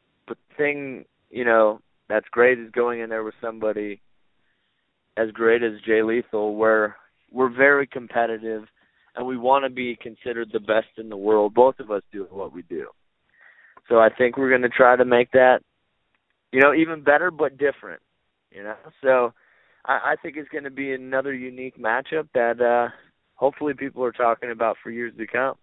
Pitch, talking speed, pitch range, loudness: 120 Hz, 185 wpm, 110-130 Hz, -21 LUFS